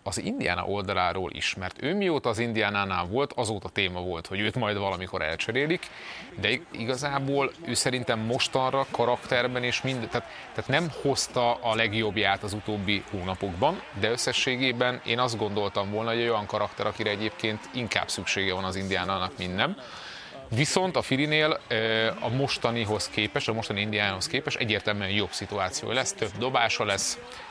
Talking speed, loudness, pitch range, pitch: 155 wpm, -27 LUFS, 100-125 Hz, 110 Hz